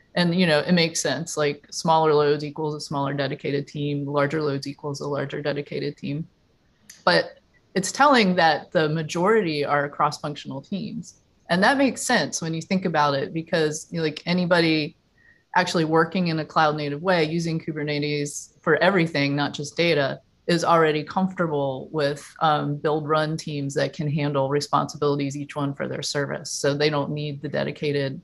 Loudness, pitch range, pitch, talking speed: -23 LUFS, 145-170 Hz, 155 Hz, 170 wpm